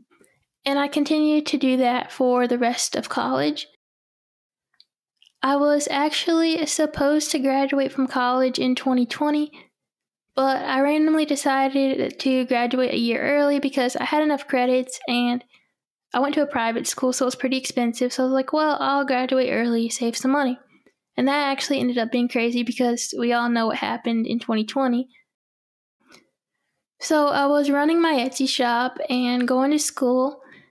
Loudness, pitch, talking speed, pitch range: -22 LUFS, 265 Hz, 165 wpm, 245-285 Hz